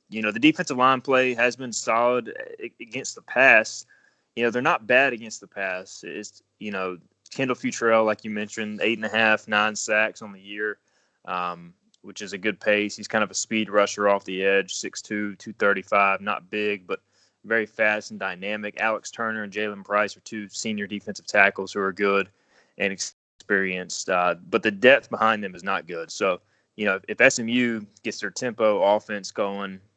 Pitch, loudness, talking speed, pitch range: 105 Hz, -23 LUFS, 190 wpm, 100-115 Hz